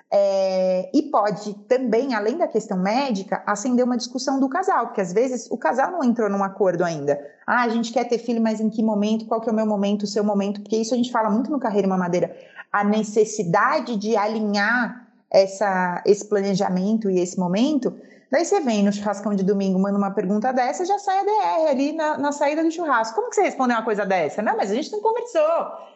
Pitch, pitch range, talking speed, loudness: 220 Hz, 200-260 Hz, 220 wpm, -22 LUFS